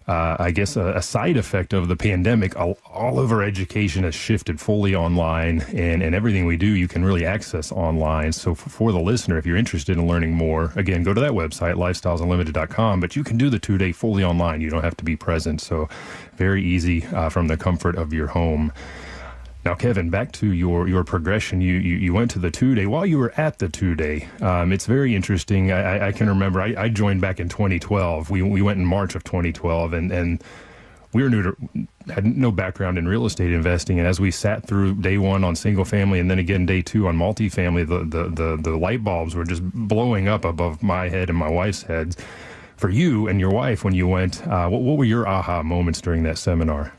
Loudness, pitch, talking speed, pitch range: -21 LUFS, 90 Hz, 225 wpm, 85-100 Hz